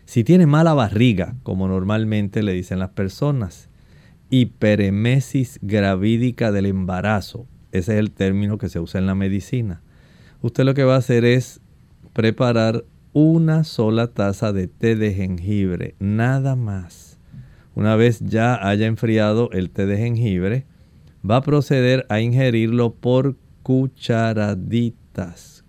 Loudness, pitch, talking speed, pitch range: -19 LUFS, 110 Hz, 135 wpm, 100-125 Hz